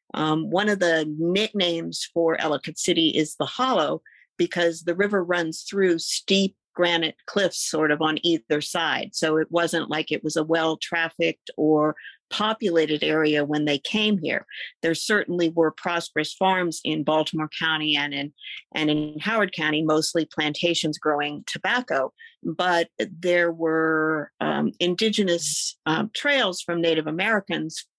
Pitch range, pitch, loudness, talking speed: 155-180 Hz, 165 Hz, -23 LUFS, 145 wpm